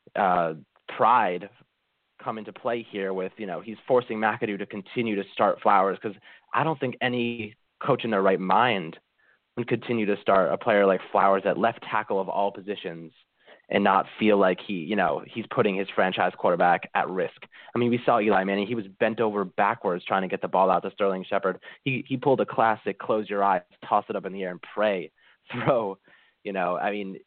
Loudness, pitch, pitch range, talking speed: -25 LUFS, 100 Hz, 95-120 Hz, 210 wpm